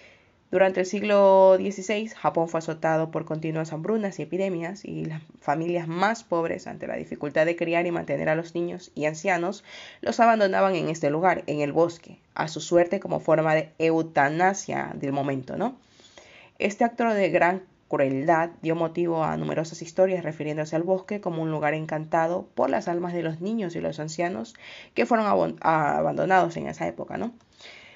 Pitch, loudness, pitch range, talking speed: 170 Hz, -25 LUFS, 155-190 Hz, 175 wpm